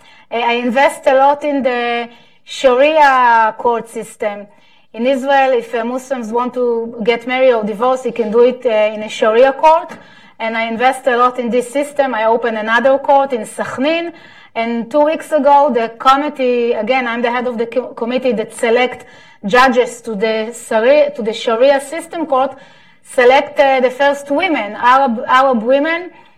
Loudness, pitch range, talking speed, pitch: -14 LUFS, 230-280 Hz, 170 wpm, 250 Hz